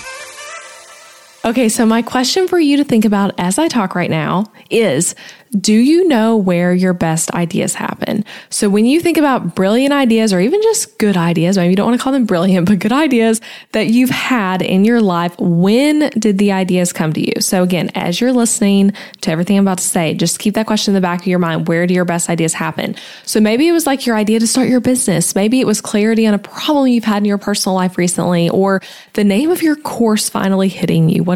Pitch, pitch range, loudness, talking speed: 210 Hz, 185-240 Hz, -14 LUFS, 230 wpm